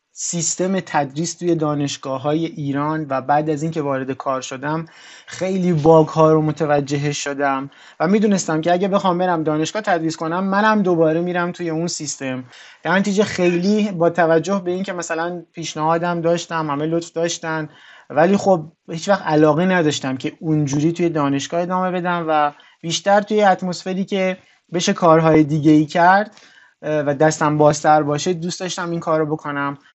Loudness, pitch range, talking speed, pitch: -18 LUFS, 150-180 Hz, 155 wpm, 165 Hz